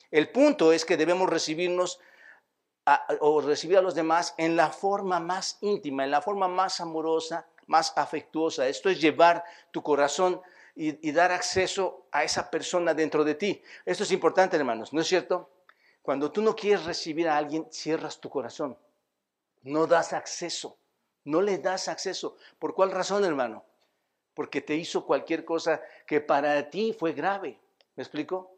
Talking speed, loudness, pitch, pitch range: 165 wpm, -27 LUFS, 170 Hz, 155-185 Hz